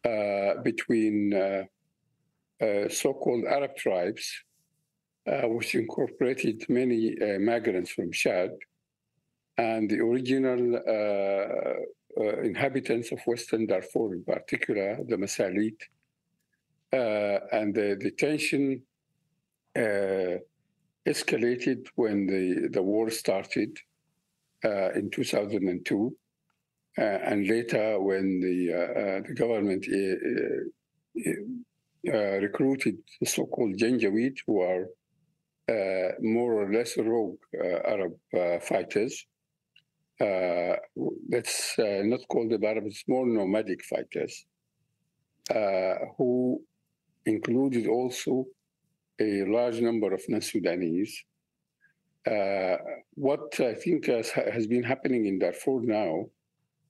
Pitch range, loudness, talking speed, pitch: 100-150 Hz, -29 LUFS, 110 wpm, 115 Hz